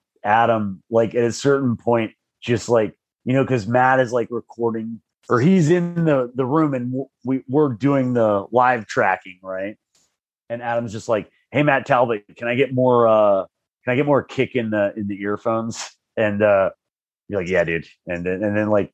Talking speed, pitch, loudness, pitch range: 195 wpm, 120 Hz, -20 LUFS, 110-130 Hz